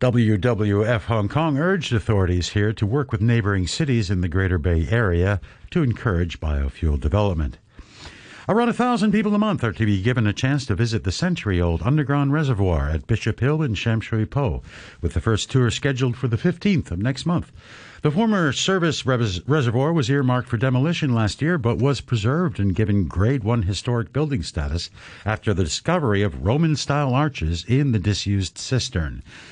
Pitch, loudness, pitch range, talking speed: 115 Hz, -22 LUFS, 100-140 Hz, 175 wpm